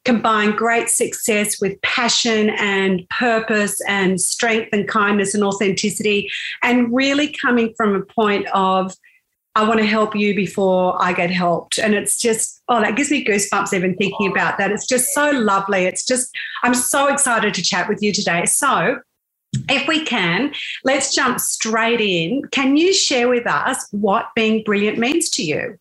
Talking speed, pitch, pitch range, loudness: 170 wpm, 220 Hz, 200-245 Hz, -17 LUFS